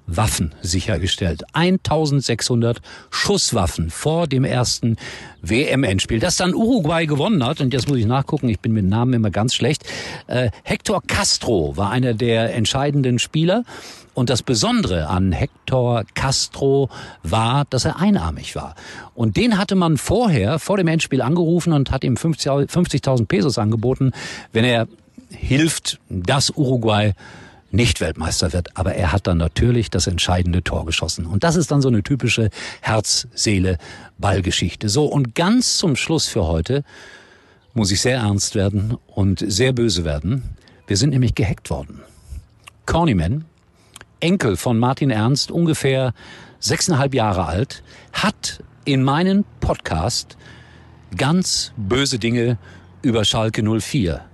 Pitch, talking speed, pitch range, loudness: 120 Hz, 140 wpm, 100-140 Hz, -19 LUFS